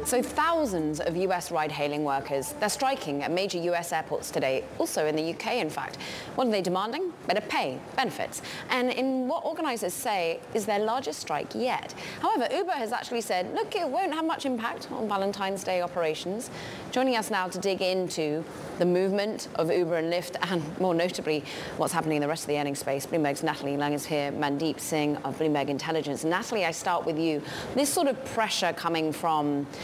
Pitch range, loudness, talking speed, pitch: 155-220 Hz, -29 LUFS, 195 wpm, 175 Hz